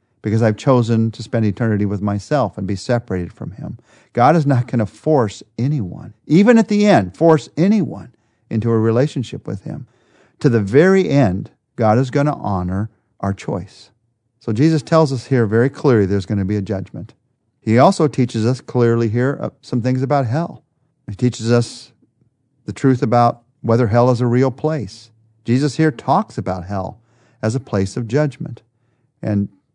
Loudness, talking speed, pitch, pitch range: -17 LUFS, 175 wpm, 120 Hz, 110-140 Hz